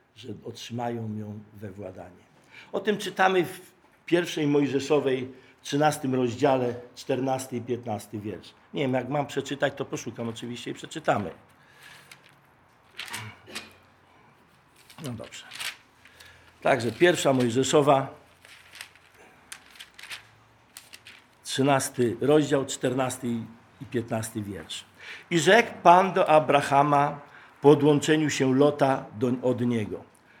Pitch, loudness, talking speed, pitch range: 135 Hz, -25 LUFS, 100 wpm, 120-150 Hz